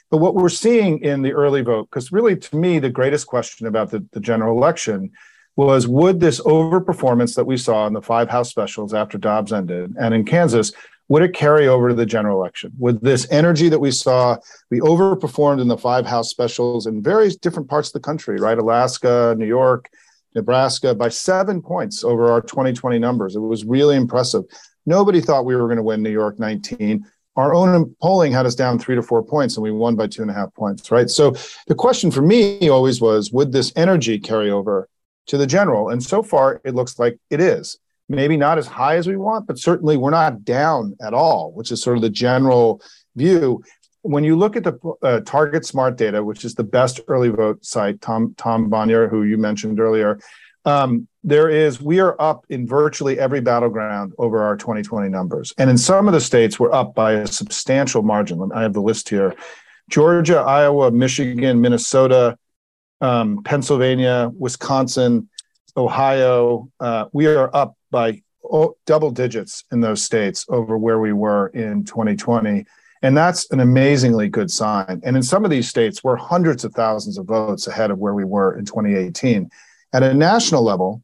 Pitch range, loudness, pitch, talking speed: 115-150 Hz, -17 LUFS, 125 Hz, 195 wpm